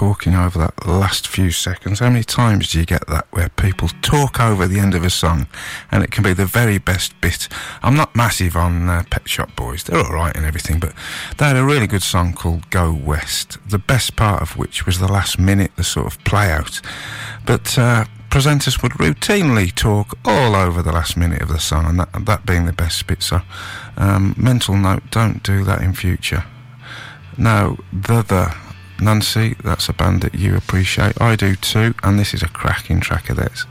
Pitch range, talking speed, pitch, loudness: 90-110 Hz, 205 wpm, 95 Hz, -17 LUFS